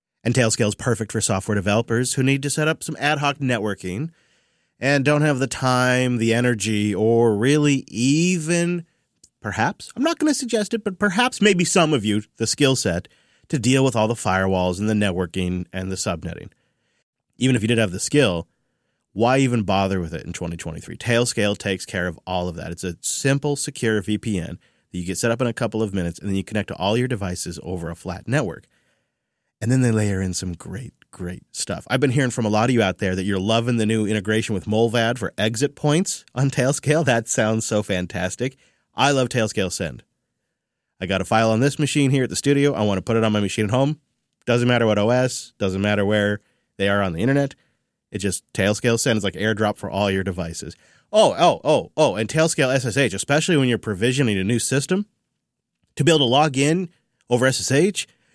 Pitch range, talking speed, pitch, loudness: 100-135 Hz, 215 wpm, 115 Hz, -21 LUFS